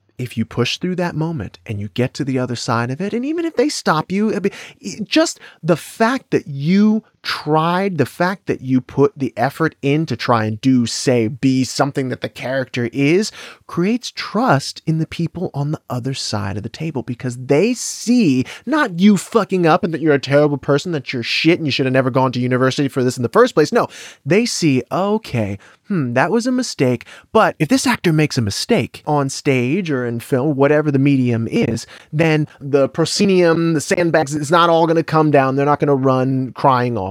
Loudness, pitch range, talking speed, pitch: -17 LUFS, 130-175 Hz, 215 wpm, 145 Hz